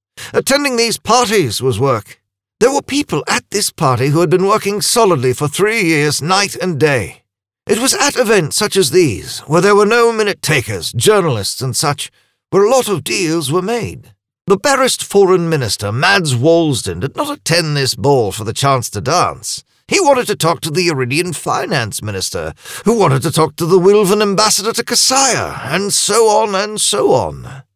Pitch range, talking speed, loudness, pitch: 135-210 Hz, 185 wpm, -13 LUFS, 175 Hz